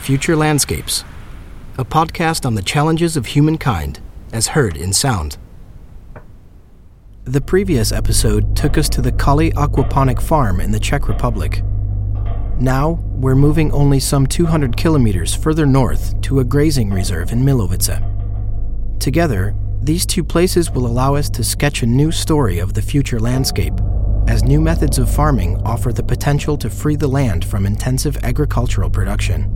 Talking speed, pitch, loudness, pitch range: 150 wpm, 115 Hz, -16 LUFS, 100-145 Hz